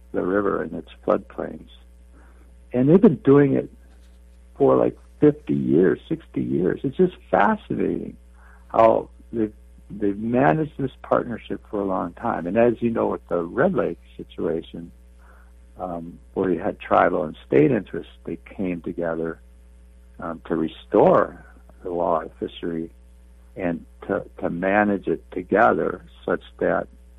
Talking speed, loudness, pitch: 140 wpm, -22 LUFS, 80 Hz